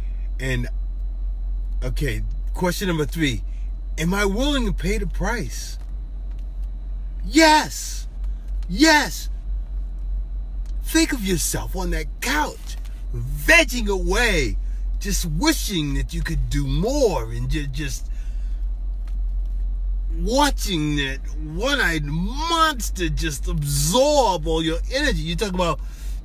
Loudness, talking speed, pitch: -22 LUFS, 100 wpm, 155 Hz